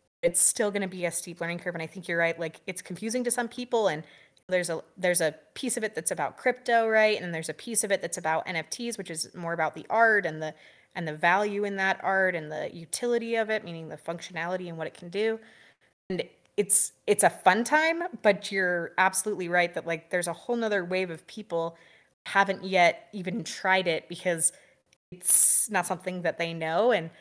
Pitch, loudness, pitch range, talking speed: 185 Hz, -25 LUFS, 165-210 Hz, 225 wpm